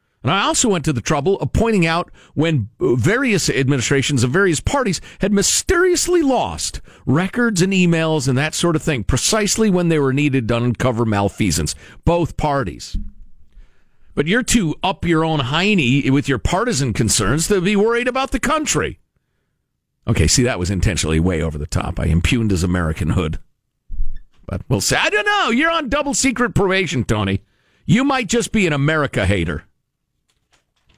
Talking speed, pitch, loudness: 170 wpm, 145 Hz, -17 LUFS